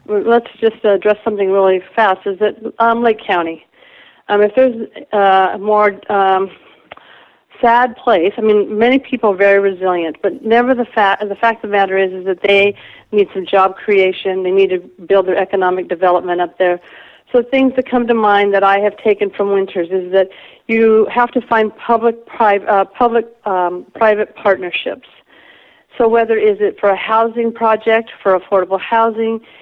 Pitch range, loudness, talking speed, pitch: 190-230 Hz, -14 LUFS, 180 wpm, 205 Hz